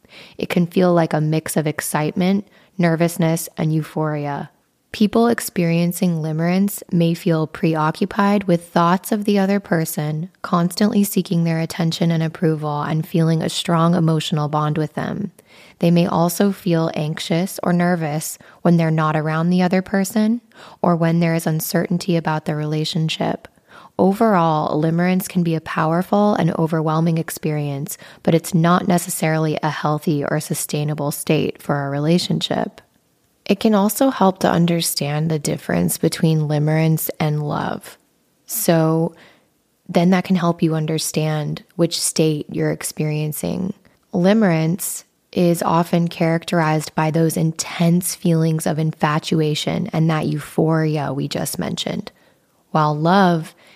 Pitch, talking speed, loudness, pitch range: 165 Hz, 135 wpm, -19 LUFS, 155-180 Hz